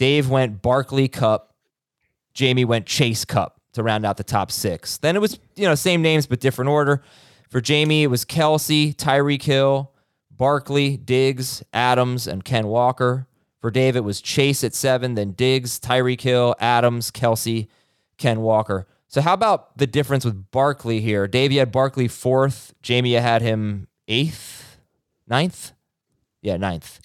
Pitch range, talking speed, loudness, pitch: 115-140 Hz, 160 wpm, -20 LUFS, 125 Hz